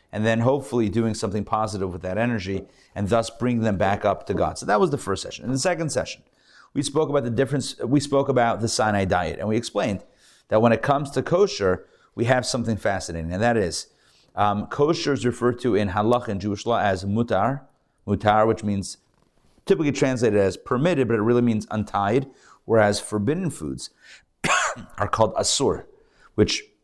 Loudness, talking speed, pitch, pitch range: -23 LUFS, 190 wpm, 115 Hz, 105-135 Hz